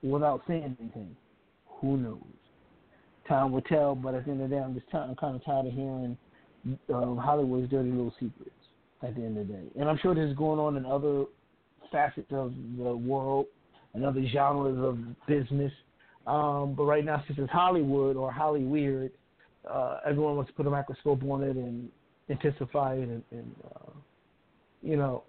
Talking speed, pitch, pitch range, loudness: 185 wpm, 135 Hz, 130-145 Hz, -31 LUFS